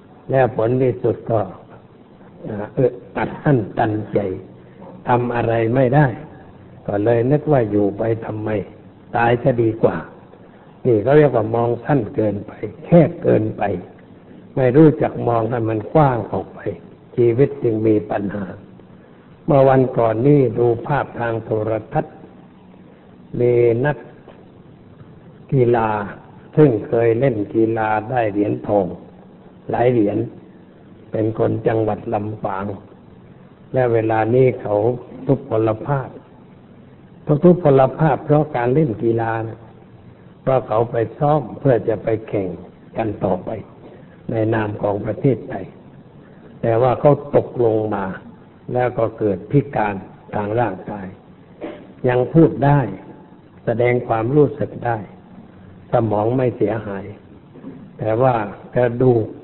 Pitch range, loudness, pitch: 110-135 Hz, -18 LUFS, 115 Hz